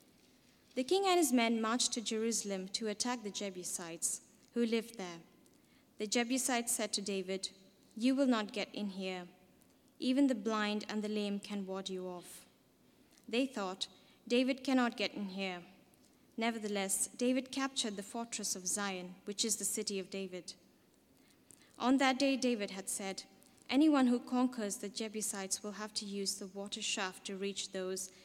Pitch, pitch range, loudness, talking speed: 210 Hz, 195-245 Hz, -36 LUFS, 165 wpm